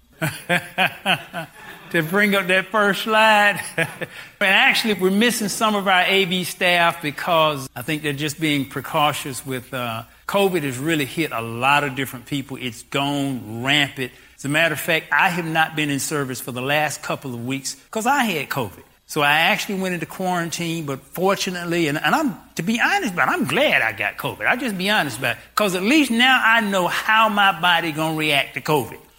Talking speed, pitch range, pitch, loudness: 200 wpm, 140-195 Hz, 165 Hz, -19 LUFS